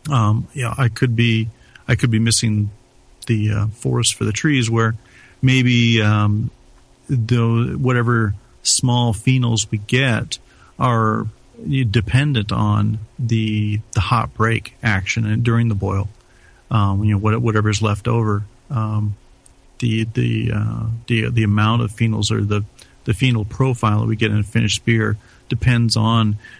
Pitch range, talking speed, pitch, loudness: 105-120 Hz, 155 wpm, 115 Hz, -18 LUFS